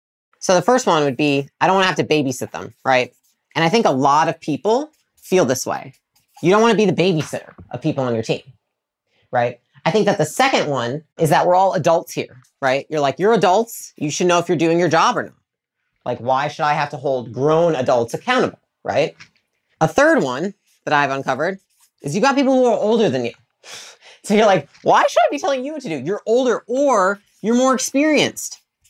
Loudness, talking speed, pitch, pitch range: -18 LUFS, 225 wpm, 165 Hz, 140-210 Hz